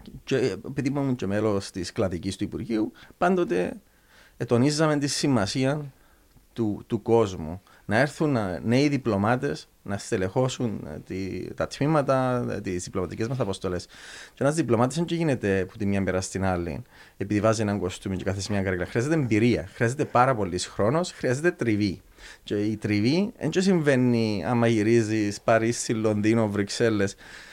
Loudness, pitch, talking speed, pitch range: -25 LUFS, 115 Hz, 145 wpm, 100-130 Hz